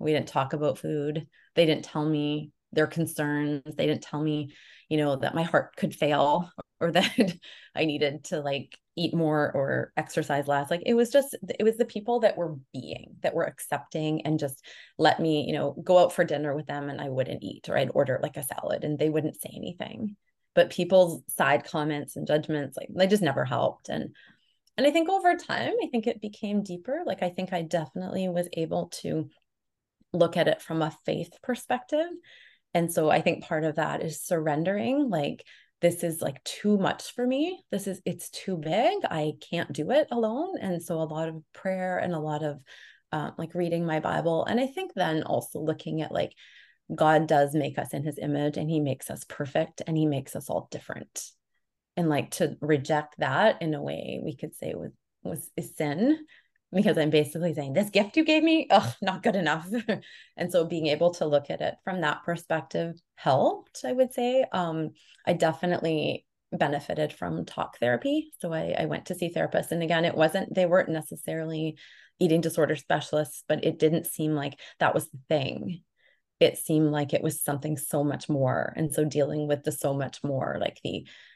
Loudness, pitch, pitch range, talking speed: -28 LUFS, 160 Hz, 150-185 Hz, 200 wpm